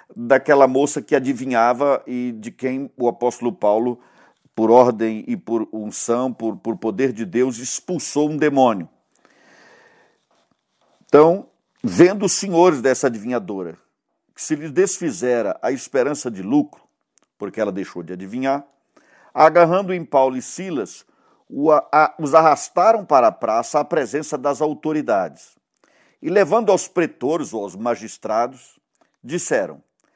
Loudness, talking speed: -19 LUFS, 125 wpm